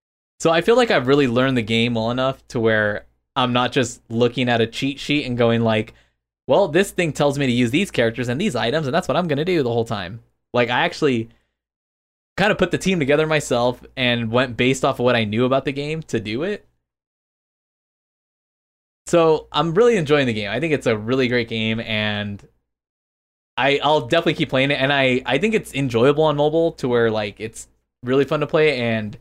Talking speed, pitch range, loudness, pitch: 220 wpm, 110-150 Hz, -19 LUFS, 125 Hz